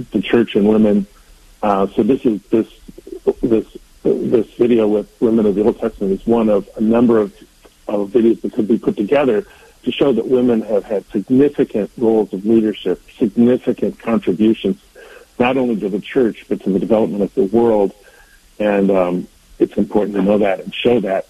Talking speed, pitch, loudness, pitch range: 185 wpm, 110 Hz, -16 LUFS, 100-120 Hz